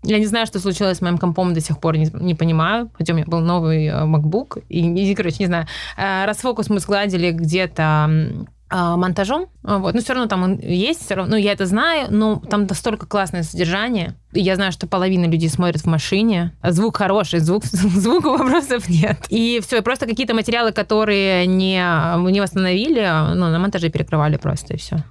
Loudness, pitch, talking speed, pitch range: -18 LUFS, 190 Hz, 195 wpm, 170-210 Hz